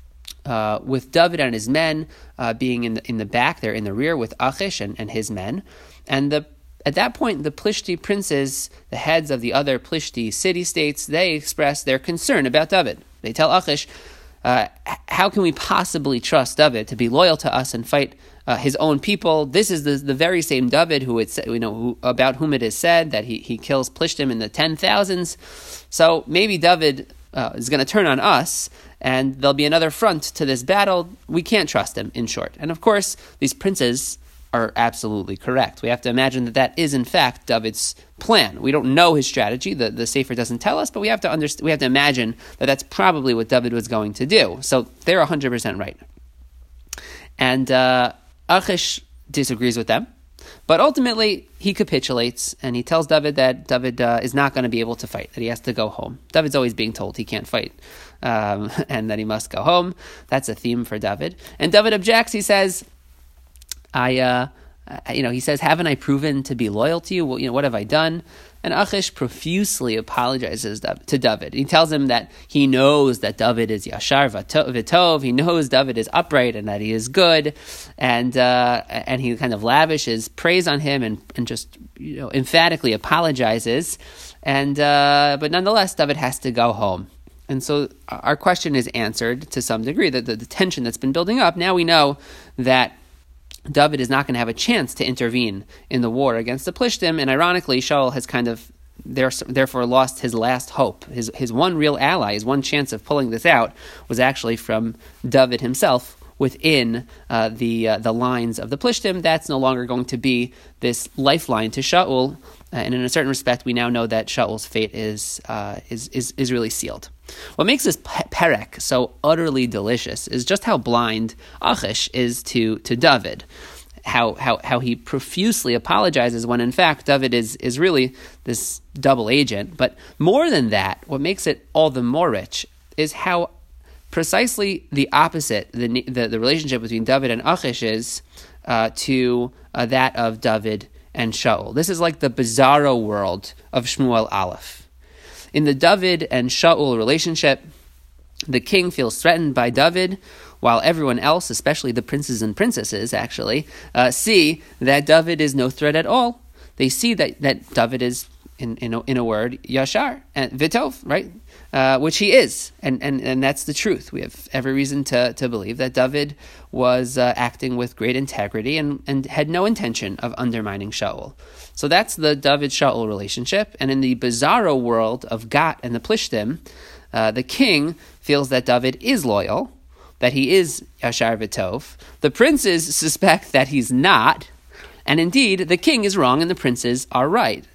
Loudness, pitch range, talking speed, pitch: -19 LUFS, 115-155 Hz, 190 wpm, 130 Hz